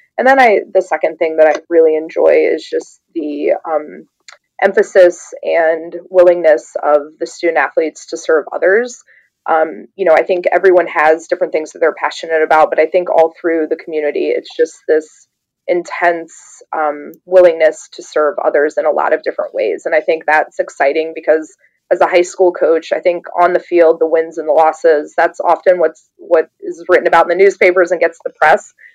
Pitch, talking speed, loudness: 175 Hz, 195 wpm, -13 LUFS